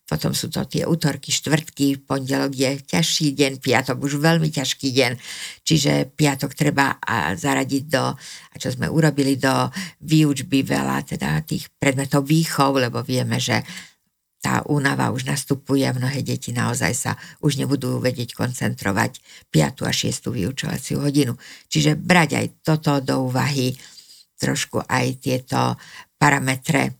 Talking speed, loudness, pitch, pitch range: 140 wpm, -21 LUFS, 140 Hz, 130-150 Hz